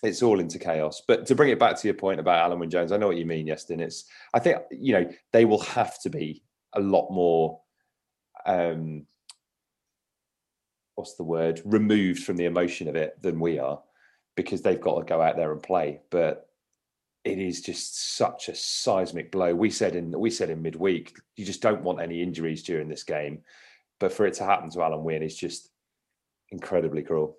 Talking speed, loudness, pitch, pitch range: 205 wpm, -26 LUFS, 85 Hz, 80-90 Hz